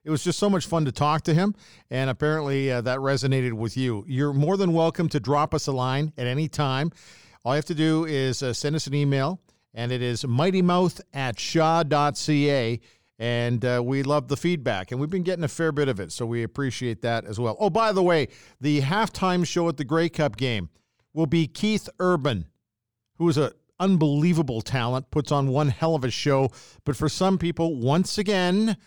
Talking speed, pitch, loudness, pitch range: 210 wpm, 145 Hz, -24 LUFS, 125-165 Hz